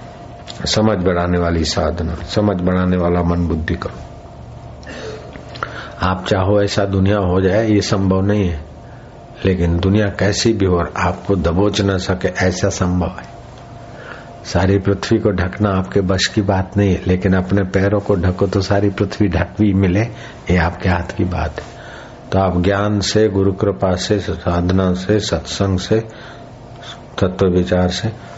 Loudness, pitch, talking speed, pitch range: -17 LUFS, 95 Hz, 155 wpm, 90-105 Hz